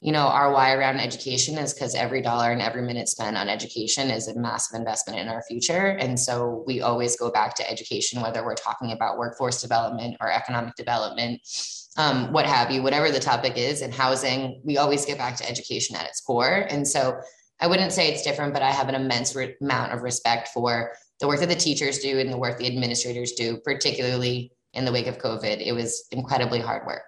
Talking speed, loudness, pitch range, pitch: 220 wpm, -24 LUFS, 120-135 Hz, 125 Hz